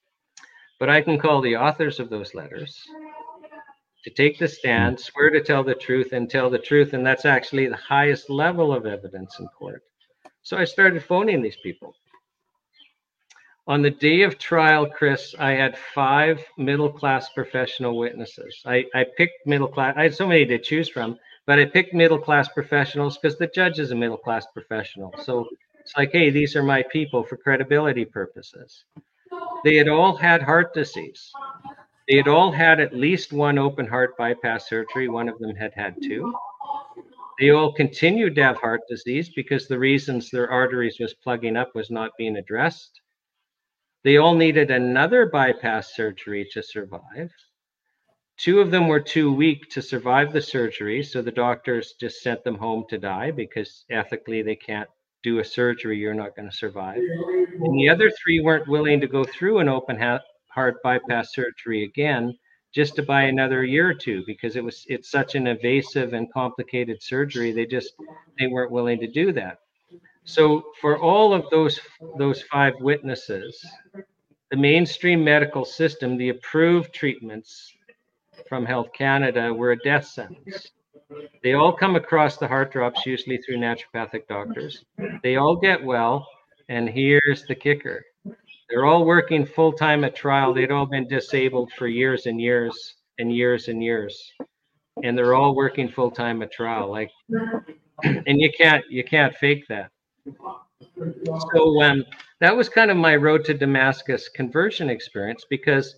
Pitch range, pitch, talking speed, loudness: 125-160 Hz, 140 Hz, 170 wpm, -21 LUFS